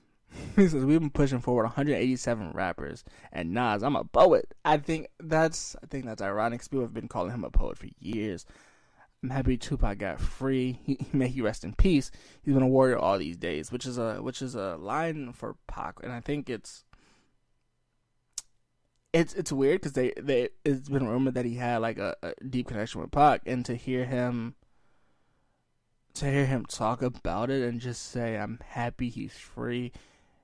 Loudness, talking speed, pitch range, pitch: -29 LUFS, 190 wpm, 120-140 Hz, 125 Hz